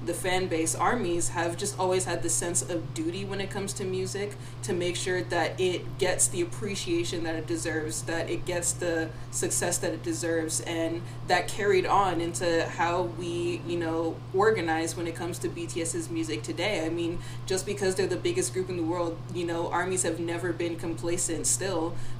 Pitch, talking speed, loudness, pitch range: 165 Hz, 195 wpm, -29 LUFS, 120-175 Hz